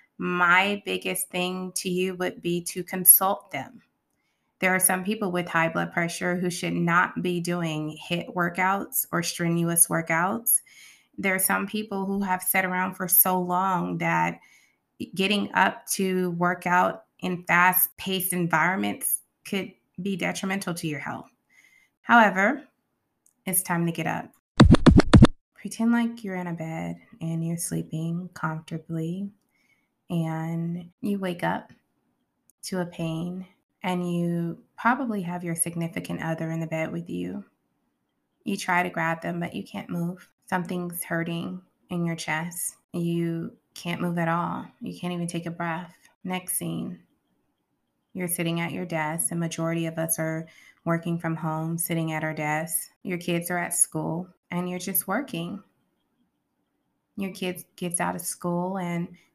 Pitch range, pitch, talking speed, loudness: 165-185 Hz, 175 Hz, 150 wpm, -25 LUFS